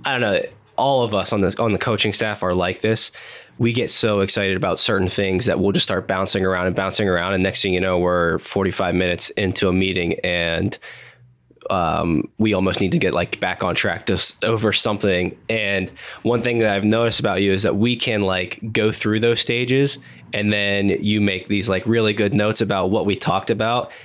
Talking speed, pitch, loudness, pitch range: 220 wpm, 100 Hz, -19 LUFS, 95-110 Hz